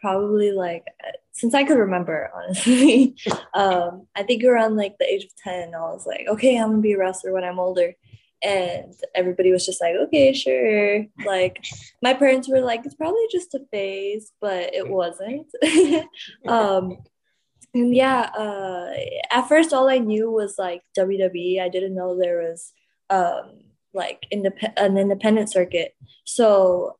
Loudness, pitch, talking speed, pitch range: -21 LUFS, 205 Hz, 160 wpm, 185-255 Hz